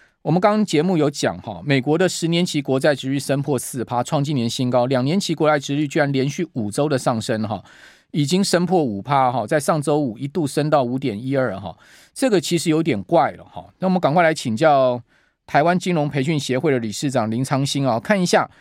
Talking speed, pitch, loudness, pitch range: 325 characters per minute, 145 Hz, -20 LUFS, 130-160 Hz